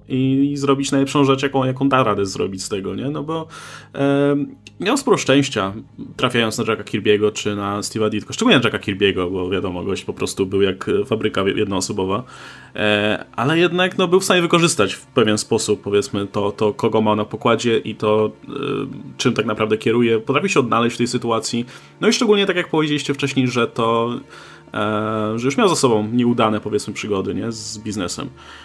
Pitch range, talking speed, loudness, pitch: 105-140 Hz, 195 wpm, -19 LUFS, 115 Hz